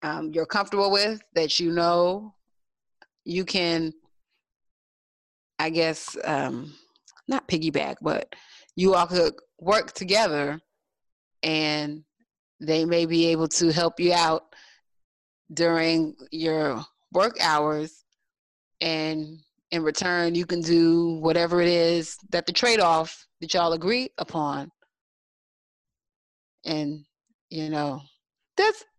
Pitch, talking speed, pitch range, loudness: 165 Hz, 110 wpm, 155-175 Hz, -24 LUFS